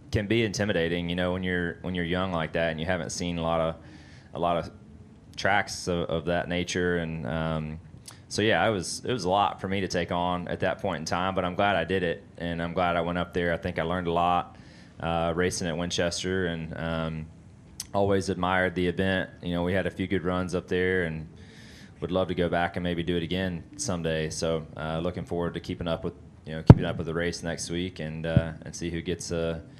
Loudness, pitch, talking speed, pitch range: -28 LUFS, 85 Hz, 250 wpm, 85-90 Hz